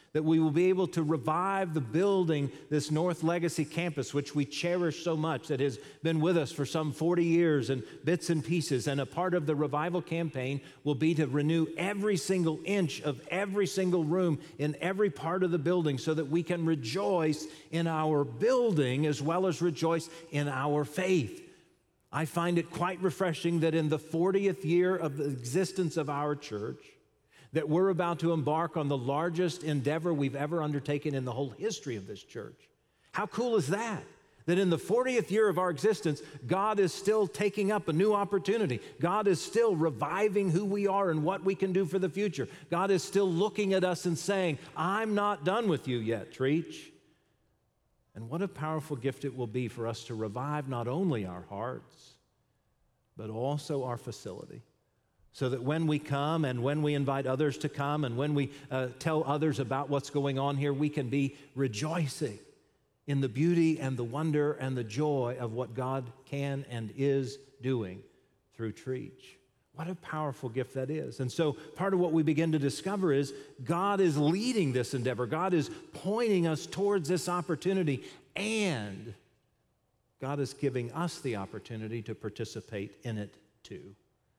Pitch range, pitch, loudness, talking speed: 140-175 Hz, 155 Hz, -31 LUFS, 185 wpm